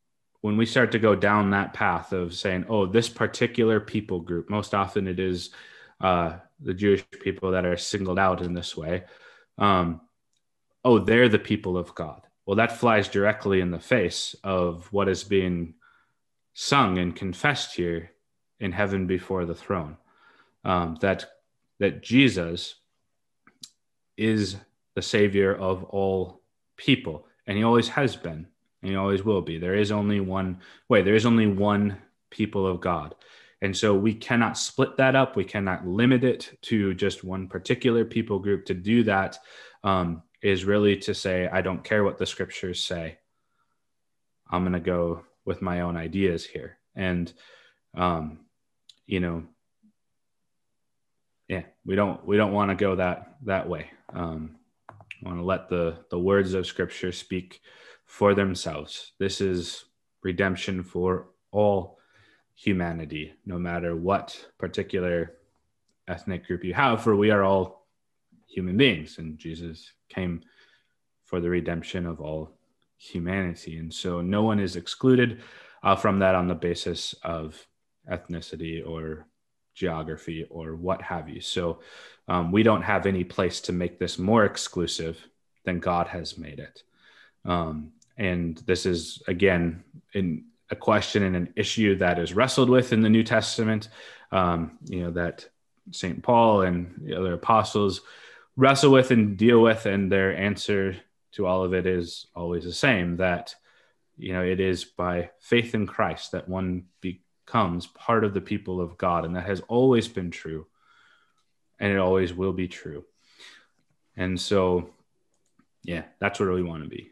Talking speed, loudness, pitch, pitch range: 155 wpm, -25 LUFS, 95 Hz, 85-105 Hz